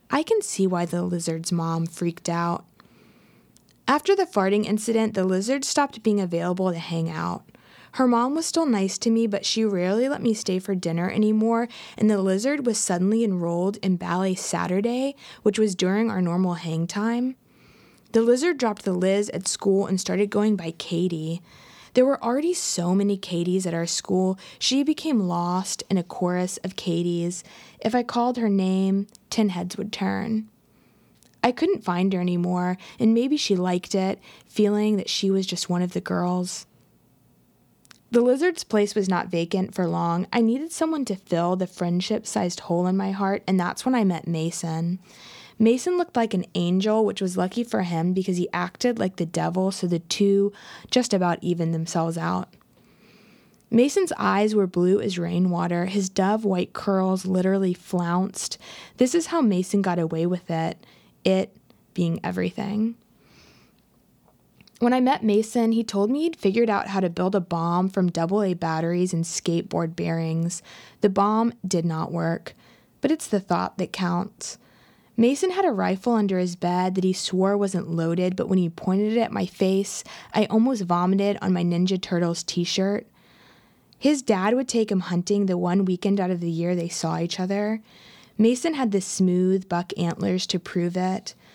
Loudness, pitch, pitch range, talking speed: -24 LUFS, 190 Hz, 180-220 Hz, 180 wpm